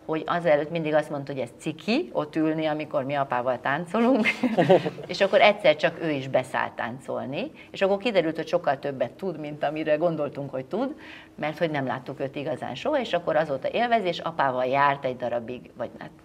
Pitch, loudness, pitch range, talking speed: 155 Hz, -26 LUFS, 140-185 Hz, 190 wpm